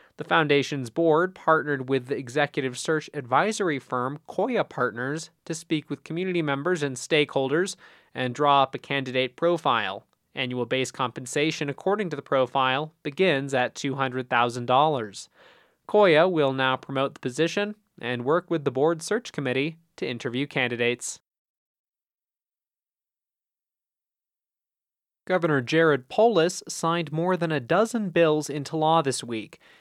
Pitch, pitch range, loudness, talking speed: 145 Hz, 130-165 Hz, -25 LUFS, 130 wpm